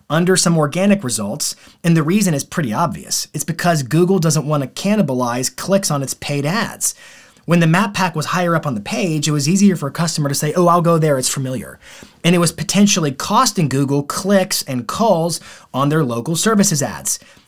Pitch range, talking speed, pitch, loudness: 145-185 Hz, 205 wpm, 165 Hz, -17 LUFS